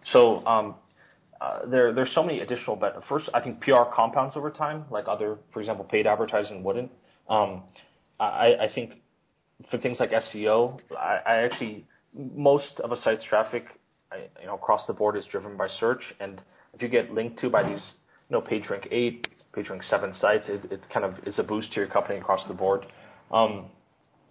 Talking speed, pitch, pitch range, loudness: 195 wpm, 120 Hz, 105-140 Hz, -26 LUFS